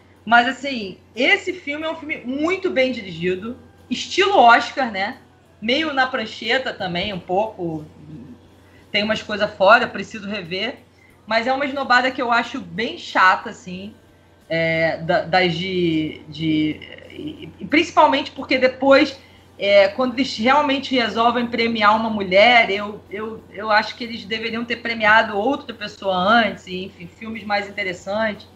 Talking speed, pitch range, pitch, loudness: 140 wpm, 195-260 Hz, 225 Hz, -19 LUFS